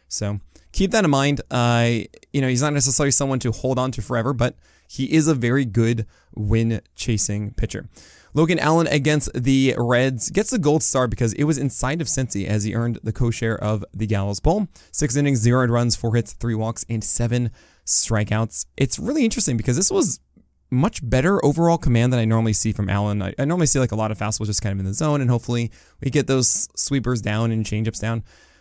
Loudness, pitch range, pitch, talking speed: -20 LUFS, 110-140 Hz, 120 Hz, 210 wpm